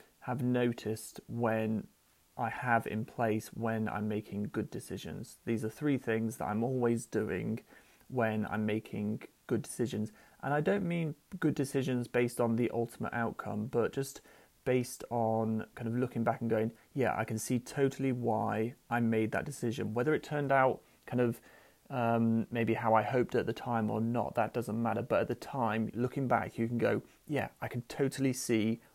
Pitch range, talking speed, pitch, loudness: 110-125 Hz, 185 wpm, 115 Hz, -34 LUFS